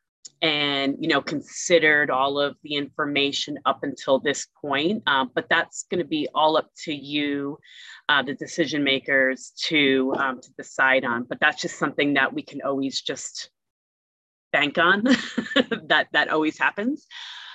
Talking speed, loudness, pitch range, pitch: 155 wpm, -23 LUFS, 135-160 Hz, 145 Hz